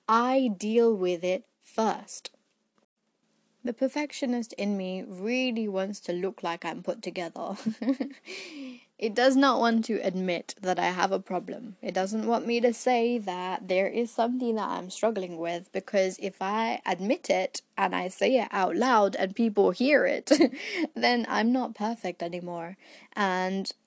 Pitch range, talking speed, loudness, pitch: 190-245 Hz, 160 wpm, -28 LUFS, 220 Hz